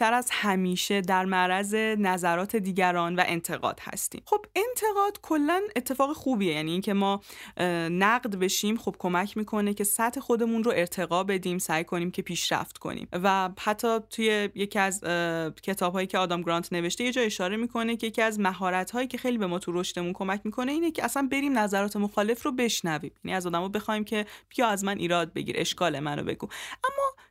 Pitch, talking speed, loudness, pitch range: 200 Hz, 180 wpm, -28 LUFS, 180-235 Hz